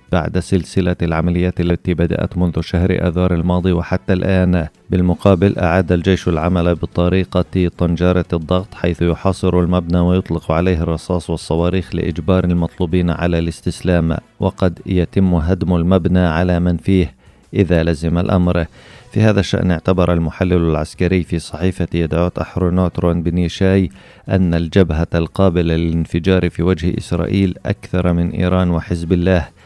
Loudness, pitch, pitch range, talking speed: -16 LUFS, 90 Hz, 85-95 Hz, 125 wpm